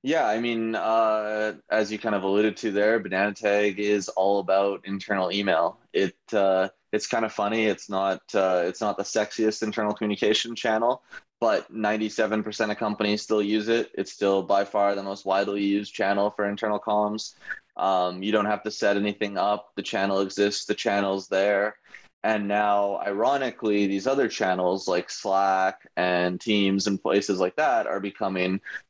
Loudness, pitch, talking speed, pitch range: -25 LUFS, 100 Hz, 175 wpm, 95-105 Hz